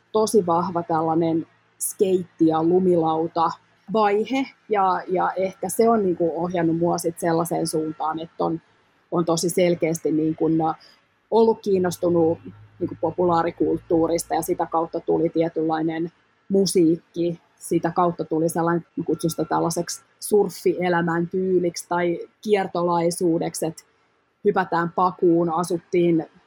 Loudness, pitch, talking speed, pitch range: -22 LUFS, 170 Hz, 110 wpm, 165-180 Hz